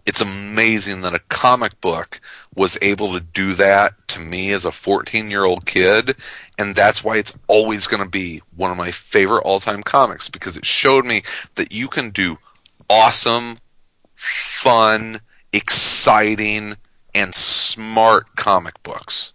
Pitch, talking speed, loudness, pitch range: 105 Hz, 150 wpm, -15 LUFS, 95-110 Hz